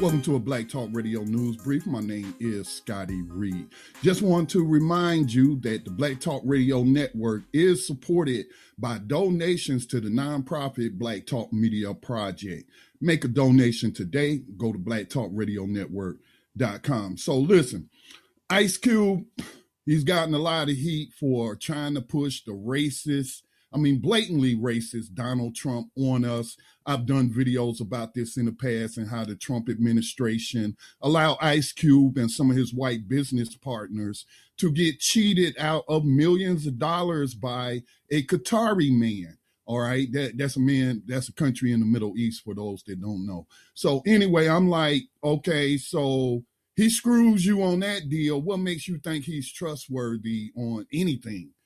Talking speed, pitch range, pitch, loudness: 160 wpm, 115-155 Hz, 130 Hz, -25 LUFS